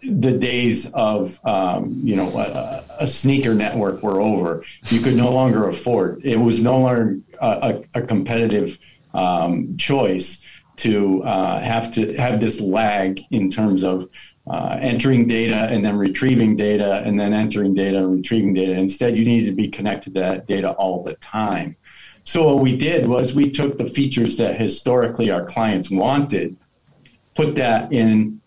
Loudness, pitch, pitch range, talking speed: -19 LUFS, 115 Hz, 100-125 Hz, 165 wpm